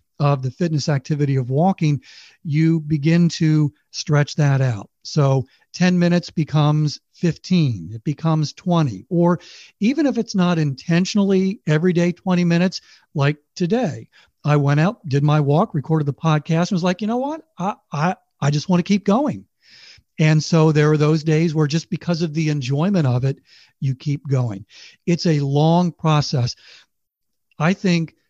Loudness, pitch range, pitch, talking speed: -19 LUFS, 145-180 Hz, 160 Hz, 165 wpm